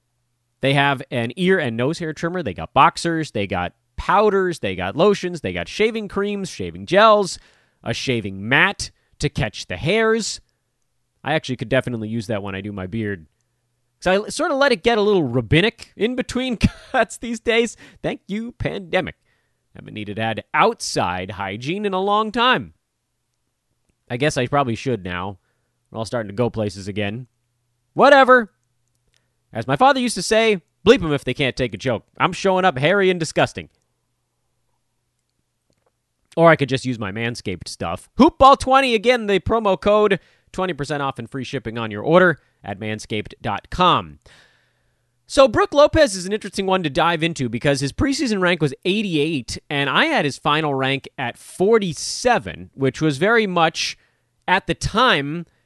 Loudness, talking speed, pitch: -19 LUFS, 170 wpm, 145 Hz